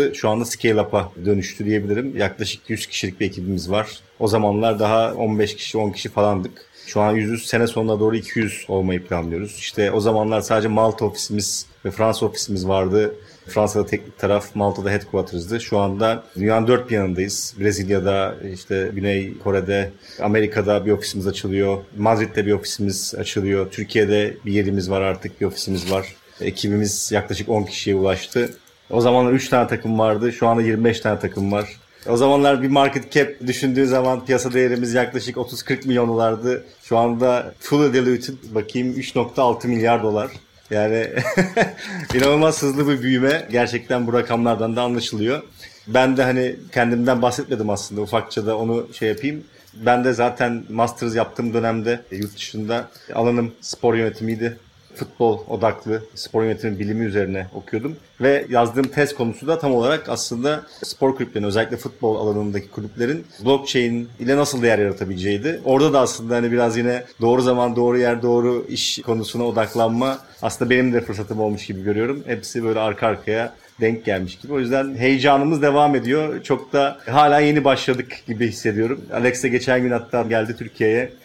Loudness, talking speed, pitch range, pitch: -20 LUFS, 155 wpm, 105-125 Hz, 115 Hz